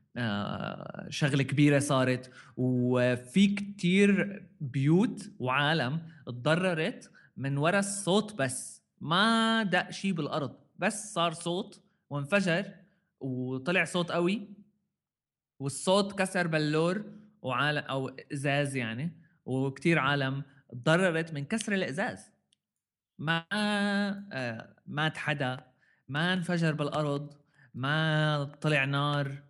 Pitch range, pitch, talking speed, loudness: 140-190 Hz, 155 Hz, 95 wpm, -30 LUFS